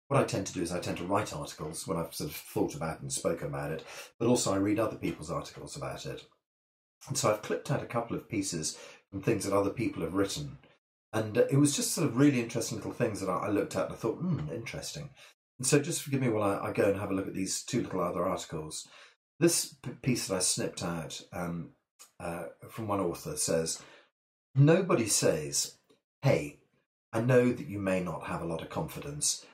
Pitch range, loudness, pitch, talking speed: 95-145 Hz, -31 LUFS, 115 Hz, 225 wpm